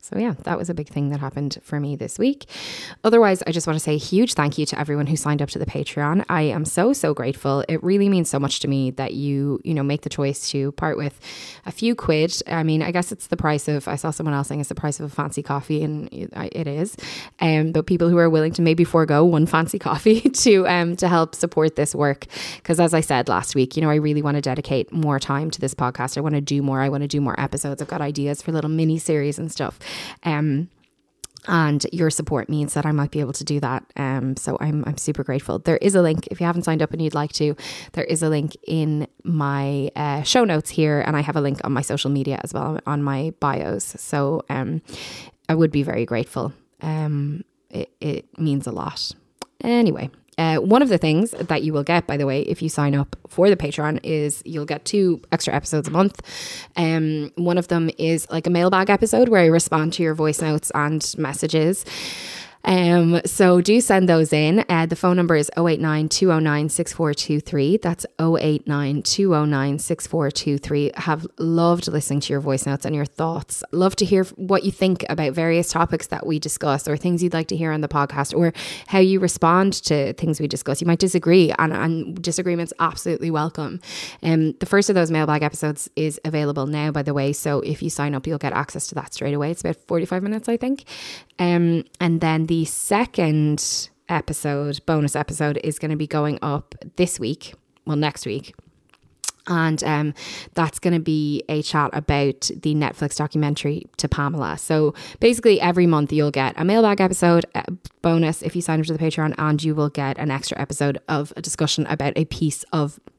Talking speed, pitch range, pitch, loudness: 220 wpm, 145-170 Hz, 155 Hz, -21 LUFS